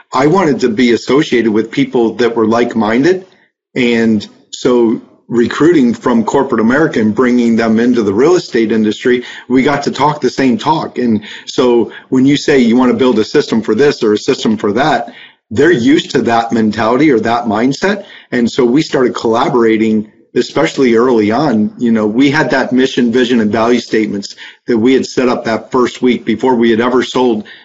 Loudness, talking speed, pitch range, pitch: -12 LUFS, 195 wpm, 115-130 Hz, 120 Hz